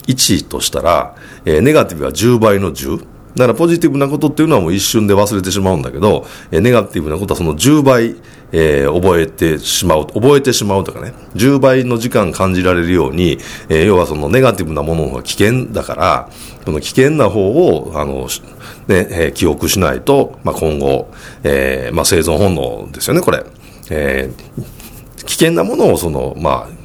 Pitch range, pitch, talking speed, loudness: 85-130 Hz, 105 Hz, 340 characters per minute, -13 LUFS